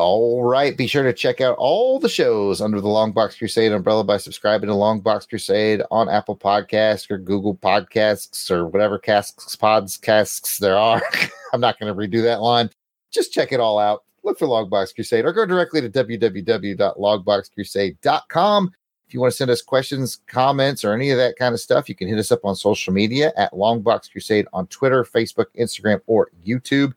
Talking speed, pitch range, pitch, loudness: 190 wpm, 105-125 Hz, 110 Hz, -19 LUFS